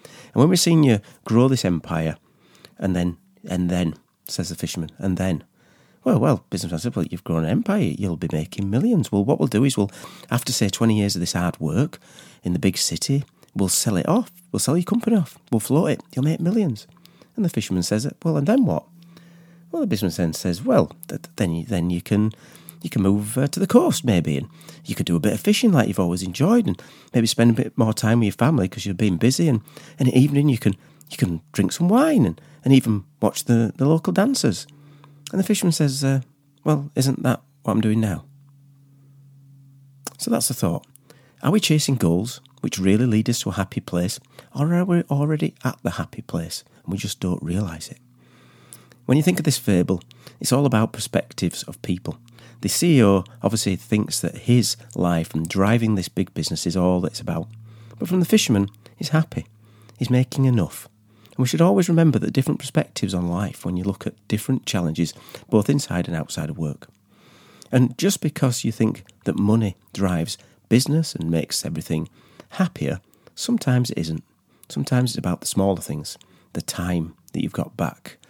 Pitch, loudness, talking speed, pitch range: 115 Hz, -22 LUFS, 205 wpm, 95-145 Hz